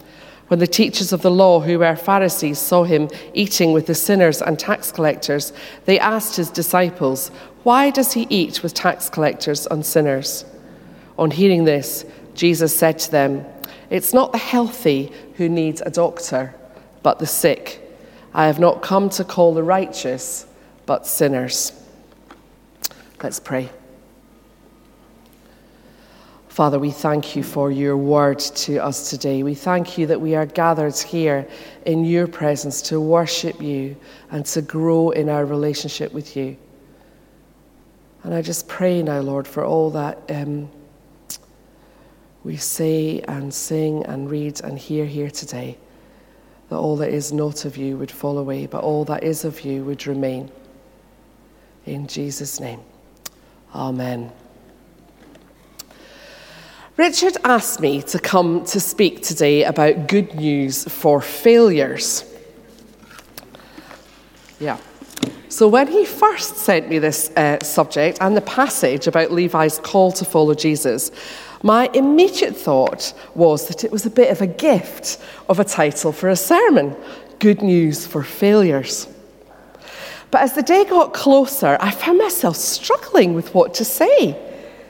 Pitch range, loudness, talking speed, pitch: 145-195 Hz, -18 LUFS, 145 wpm, 160 Hz